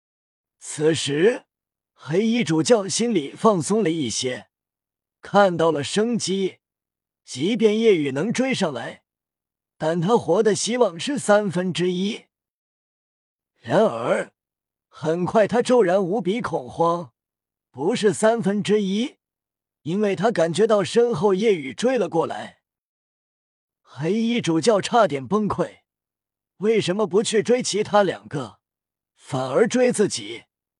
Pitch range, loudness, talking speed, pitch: 160-220 Hz, -21 LUFS, 175 characters per minute, 195 Hz